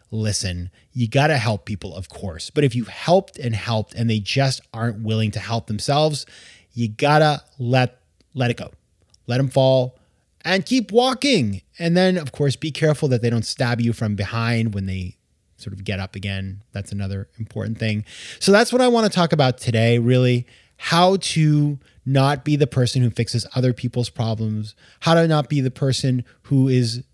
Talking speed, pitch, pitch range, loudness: 195 wpm, 125 Hz, 110-145 Hz, -20 LUFS